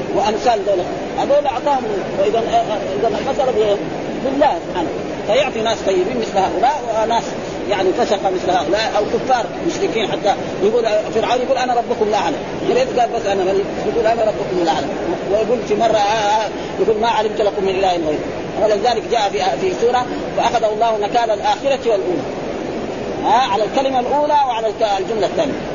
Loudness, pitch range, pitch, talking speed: -17 LUFS, 210-250 Hz, 225 Hz, 160 wpm